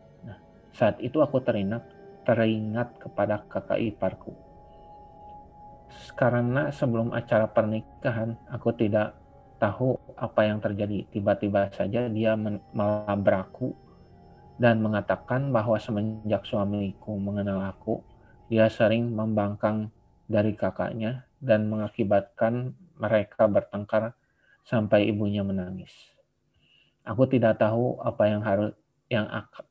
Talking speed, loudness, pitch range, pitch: 100 wpm, -27 LUFS, 105-120 Hz, 110 Hz